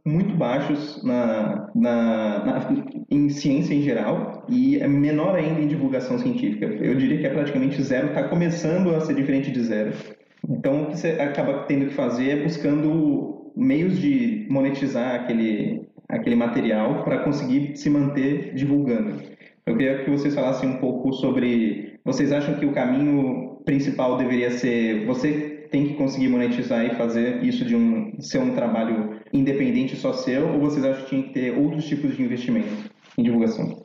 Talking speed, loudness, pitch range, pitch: 170 wpm, -23 LUFS, 130-165 Hz, 145 Hz